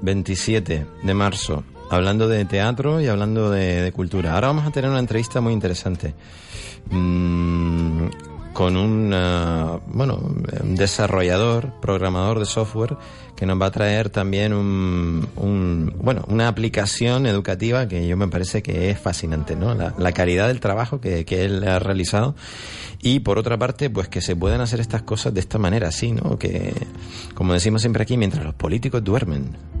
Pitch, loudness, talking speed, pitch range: 100 Hz, -21 LUFS, 170 wpm, 90-110 Hz